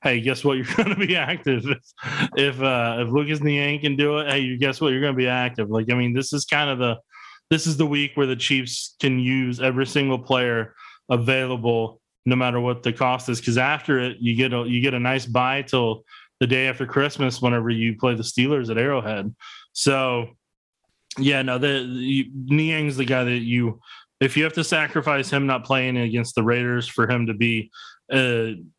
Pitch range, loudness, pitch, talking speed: 120-140 Hz, -22 LUFS, 130 Hz, 210 wpm